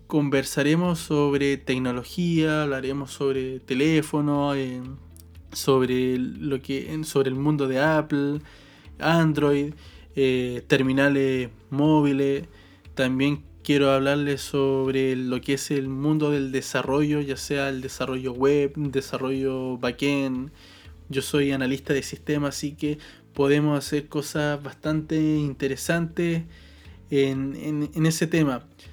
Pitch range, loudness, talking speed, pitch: 130-150 Hz, -24 LUFS, 110 wpm, 140 Hz